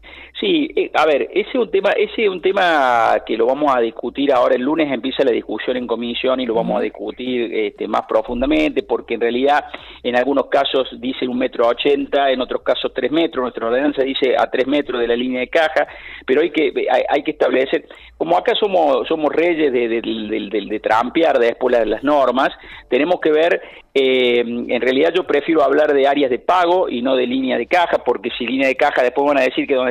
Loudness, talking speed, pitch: -17 LUFS, 225 wpm, 140 Hz